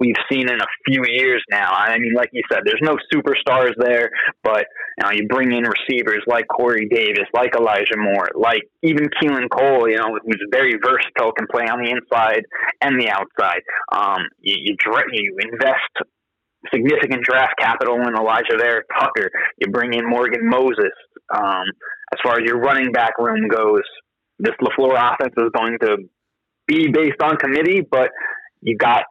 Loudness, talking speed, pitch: -17 LUFS, 175 wpm, 135 Hz